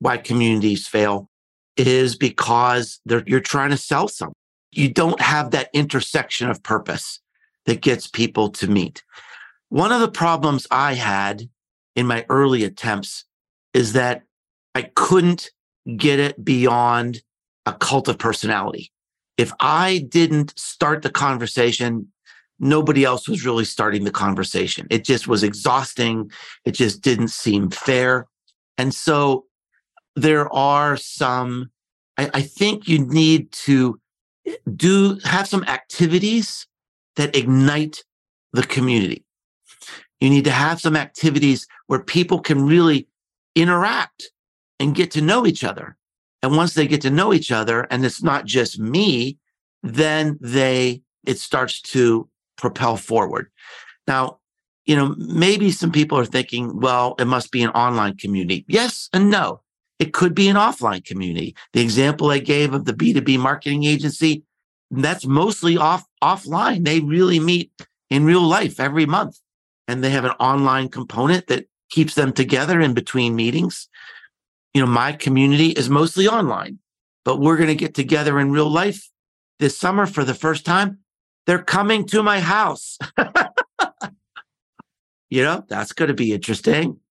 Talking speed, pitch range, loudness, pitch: 145 wpm, 125-165 Hz, -19 LUFS, 140 Hz